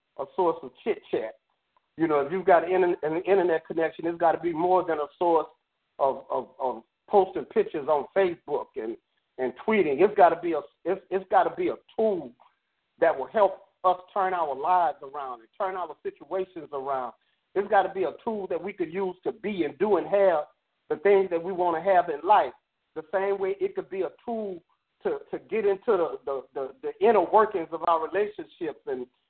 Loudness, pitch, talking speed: -26 LUFS, 195 Hz, 215 wpm